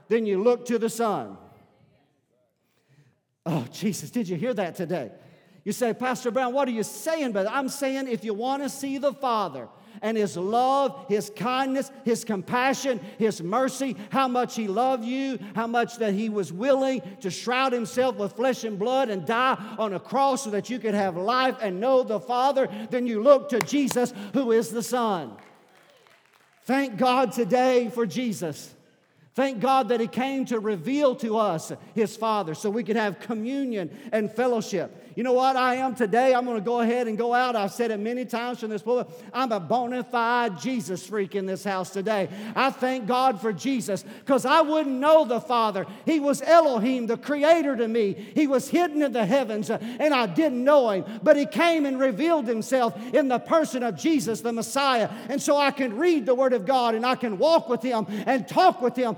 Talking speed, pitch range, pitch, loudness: 200 wpm, 215-260 Hz, 240 Hz, -25 LUFS